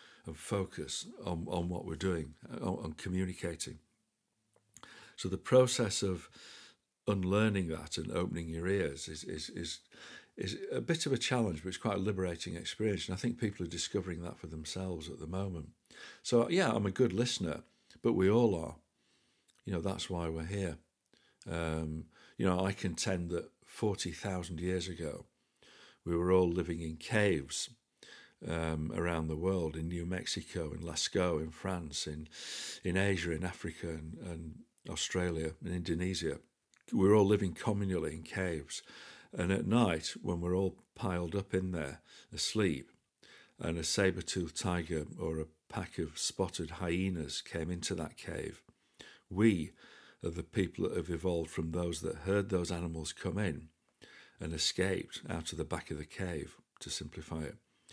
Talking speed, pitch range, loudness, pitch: 165 wpm, 80-95 Hz, -36 LUFS, 90 Hz